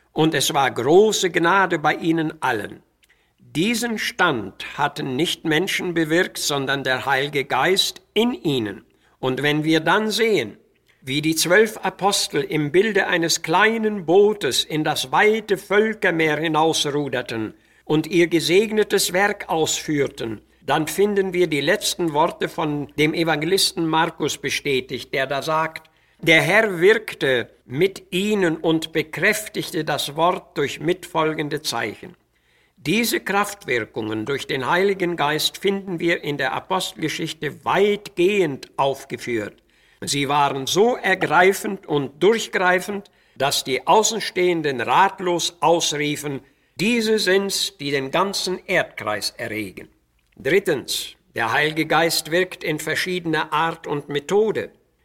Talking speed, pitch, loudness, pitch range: 120 wpm, 165 Hz, -20 LUFS, 150-195 Hz